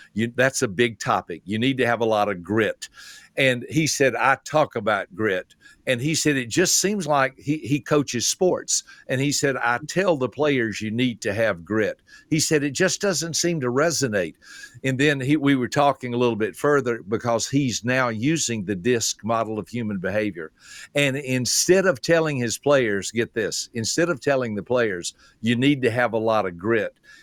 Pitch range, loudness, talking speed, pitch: 115-145 Hz, -22 LUFS, 205 wpm, 130 Hz